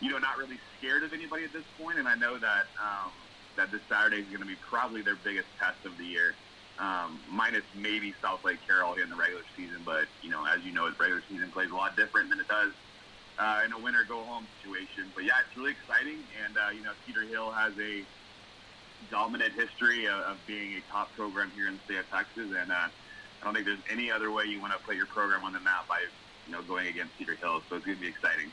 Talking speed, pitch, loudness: 250 wpm, 110 Hz, -31 LUFS